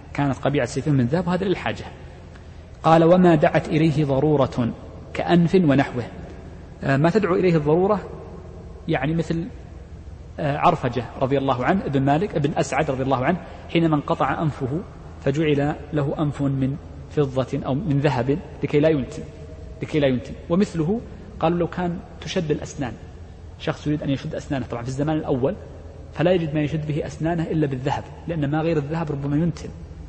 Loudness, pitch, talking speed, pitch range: -22 LUFS, 145 Hz, 155 wpm, 120-160 Hz